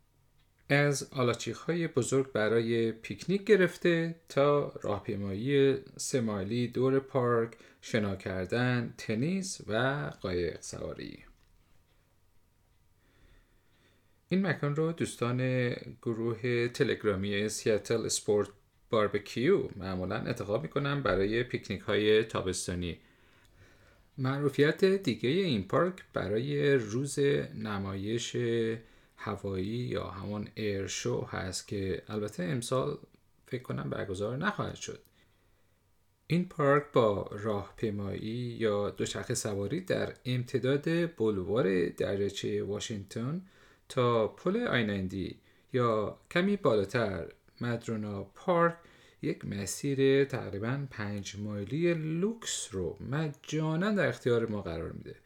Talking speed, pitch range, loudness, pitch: 95 wpm, 100-140 Hz, -32 LUFS, 115 Hz